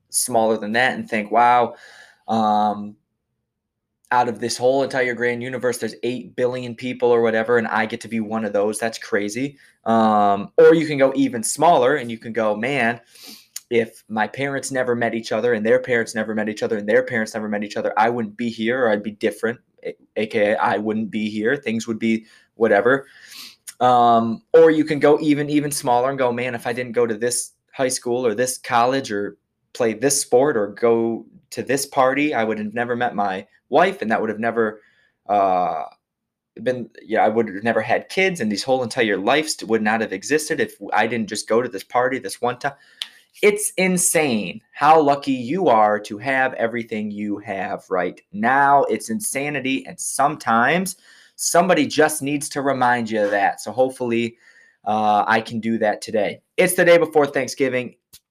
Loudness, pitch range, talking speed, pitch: -20 LUFS, 110-135 Hz, 195 wpm, 120 Hz